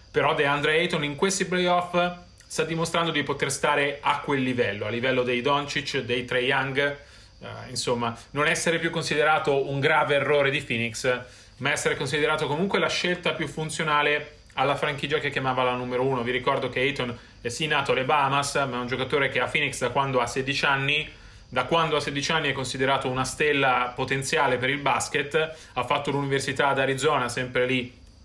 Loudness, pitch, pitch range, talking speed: -25 LUFS, 140 Hz, 125-150 Hz, 185 wpm